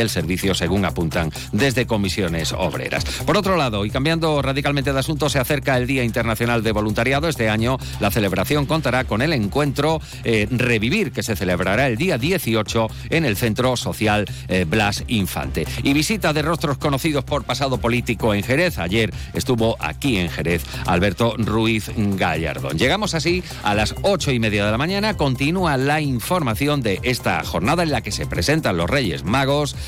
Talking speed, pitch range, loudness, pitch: 175 wpm, 110-145 Hz, -20 LUFS, 125 Hz